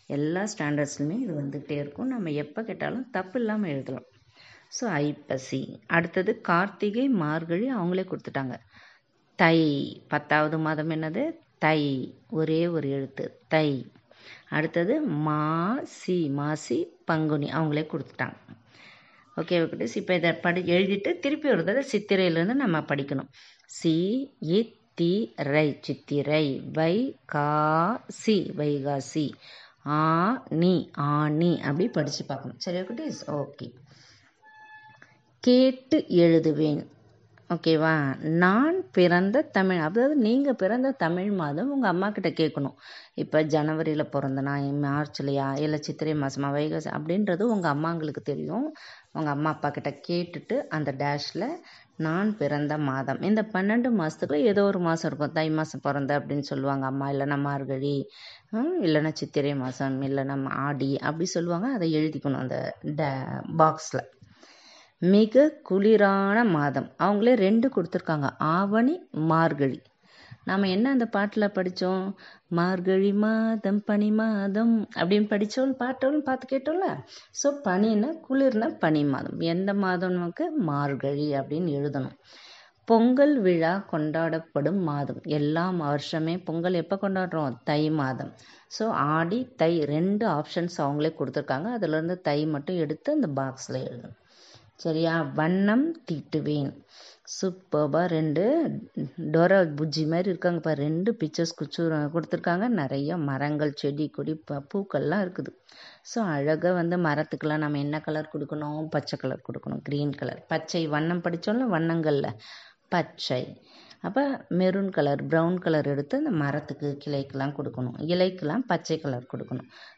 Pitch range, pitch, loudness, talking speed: 145-195 Hz, 160 Hz, -26 LUFS, 120 wpm